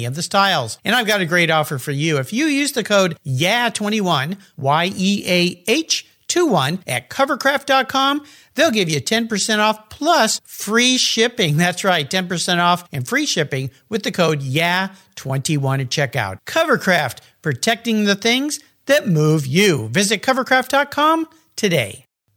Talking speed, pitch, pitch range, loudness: 140 wpm, 195 Hz, 155-240 Hz, -18 LUFS